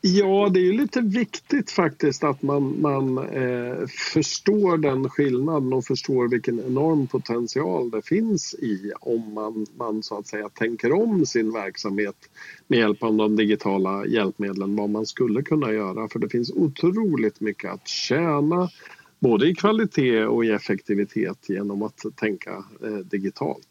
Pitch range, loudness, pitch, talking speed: 110-160 Hz, -23 LUFS, 130 Hz, 155 wpm